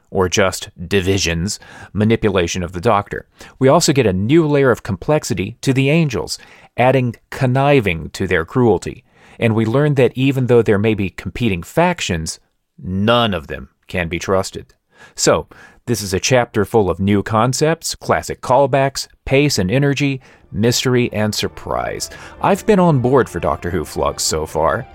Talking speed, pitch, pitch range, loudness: 160 wpm, 115 Hz, 95-135 Hz, -17 LUFS